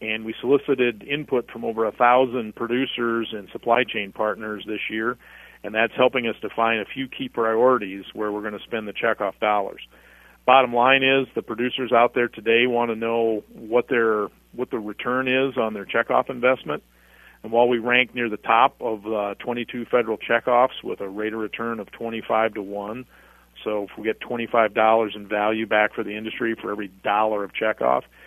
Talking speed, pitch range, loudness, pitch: 195 wpm, 105-120 Hz, -22 LUFS, 115 Hz